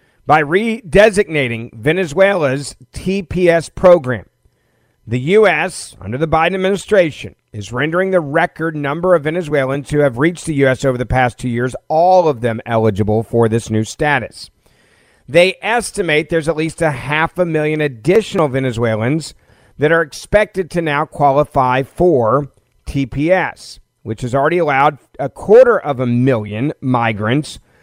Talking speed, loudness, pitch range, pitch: 140 wpm, -15 LUFS, 125-170 Hz, 145 Hz